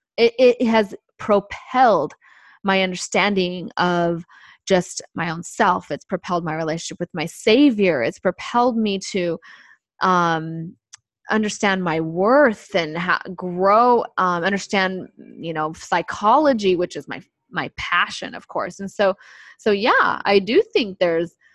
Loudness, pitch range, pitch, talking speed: -20 LUFS, 175-220 Hz, 190 Hz, 135 wpm